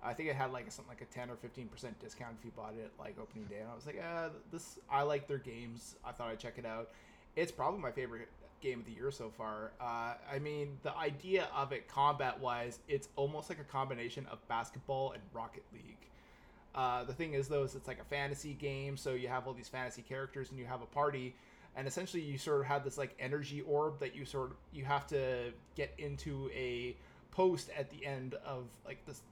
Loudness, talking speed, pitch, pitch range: -41 LUFS, 230 wpm, 135 Hz, 120-145 Hz